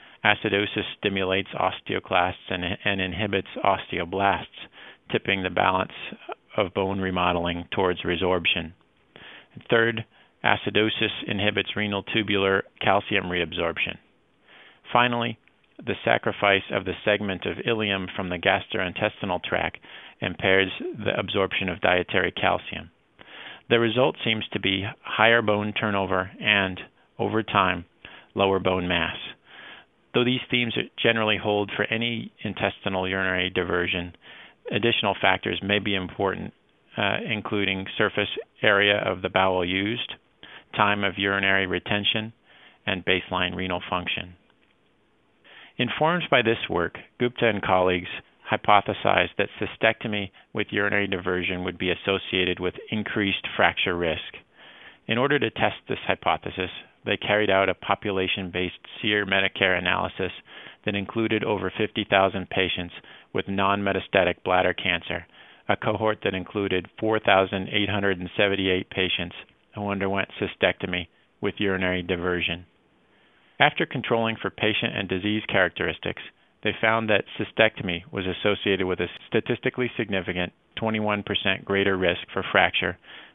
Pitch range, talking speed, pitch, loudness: 95-105 Hz, 120 wpm, 100 Hz, -24 LUFS